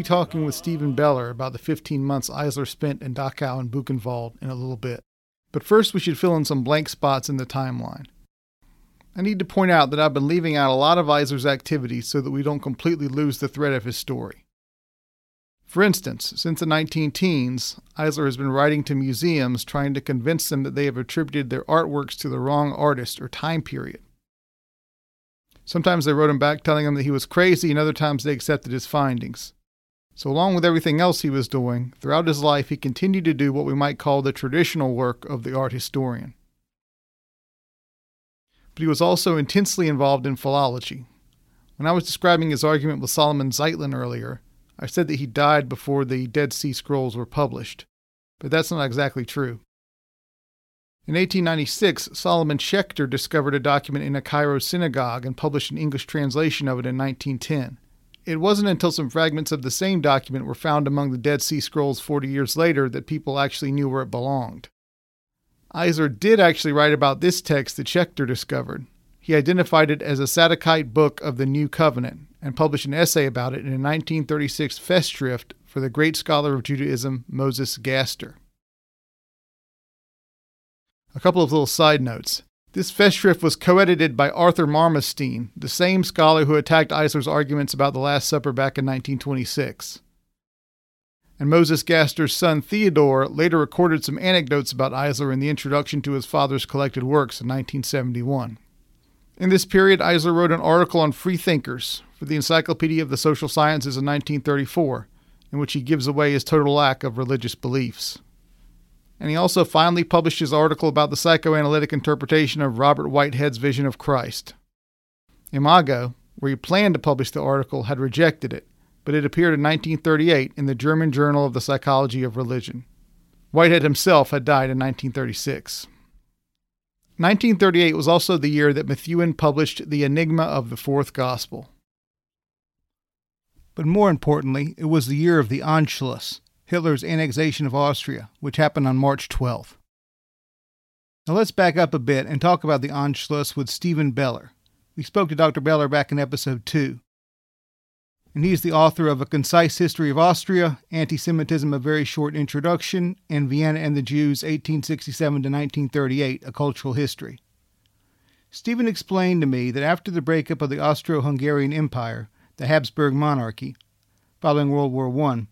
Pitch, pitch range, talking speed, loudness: 145 Hz, 135-160 Hz, 175 wpm, -21 LUFS